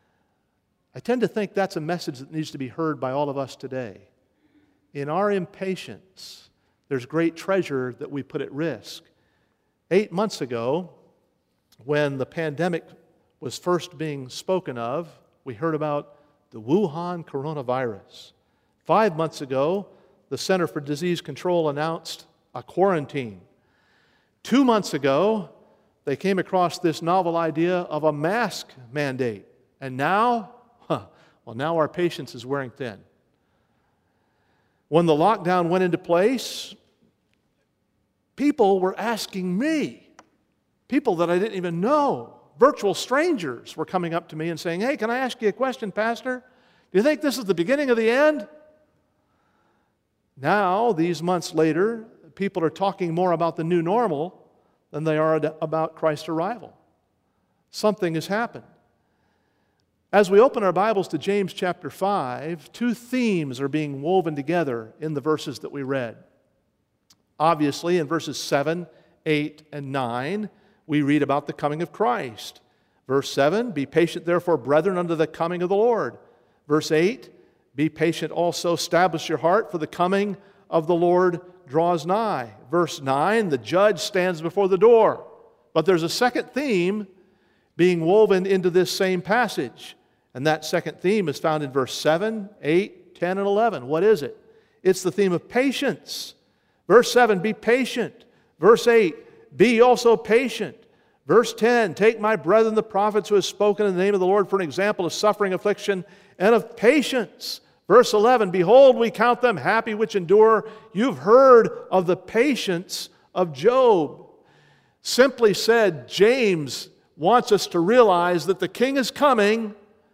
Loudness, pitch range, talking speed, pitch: -22 LUFS, 155-215 Hz, 155 wpm, 180 Hz